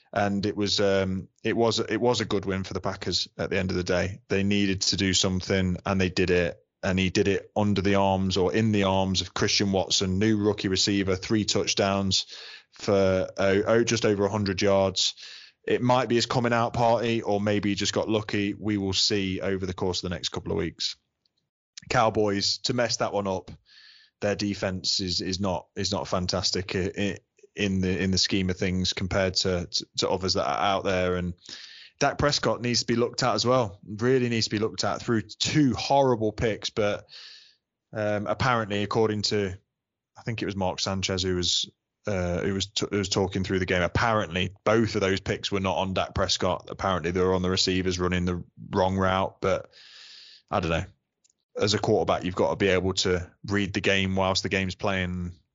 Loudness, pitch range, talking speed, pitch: -26 LUFS, 95-105 Hz, 210 wpm, 100 Hz